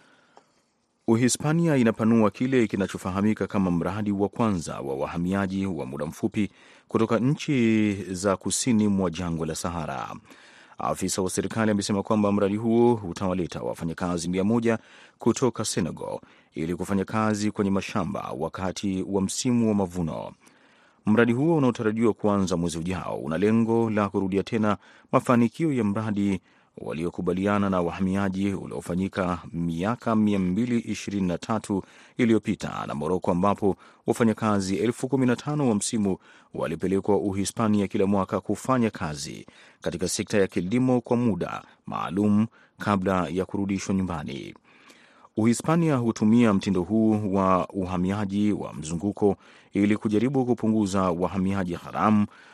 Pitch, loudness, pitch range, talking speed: 100 Hz, -25 LUFS, 95-115 Hz, 115 wpm